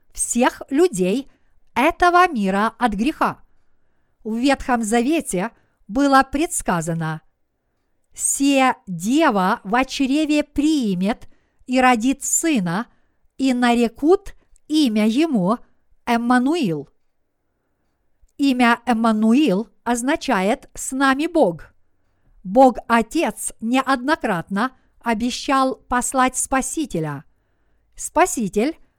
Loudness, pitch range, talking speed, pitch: -19 LUFS, 215-280 Hz, 75 wpm, 250 Hz